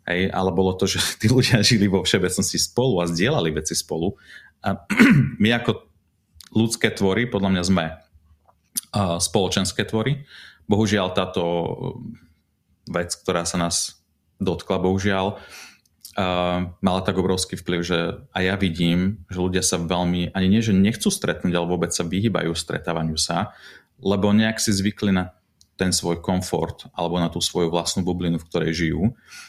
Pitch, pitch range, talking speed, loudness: 95 Hz, 85-100 Hz, 155 wpm, -22 LUFS